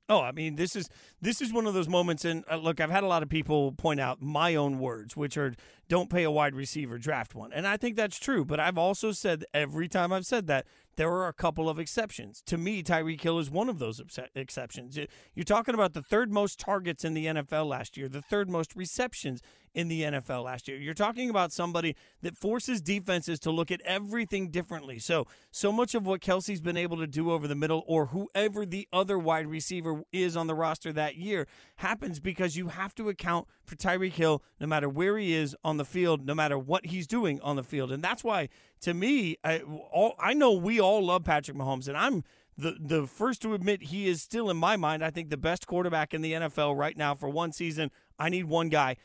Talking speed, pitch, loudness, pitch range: 230 wpm, 165 Hz, -30 LUFS, 150-190 Hz